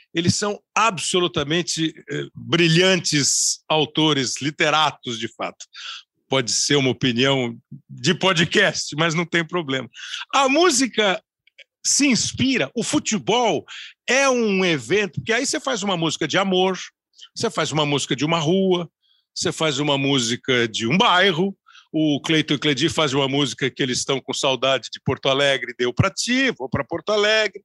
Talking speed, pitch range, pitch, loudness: 150 wpm, 140-190 Hz, 160 Hz, -20 LUFS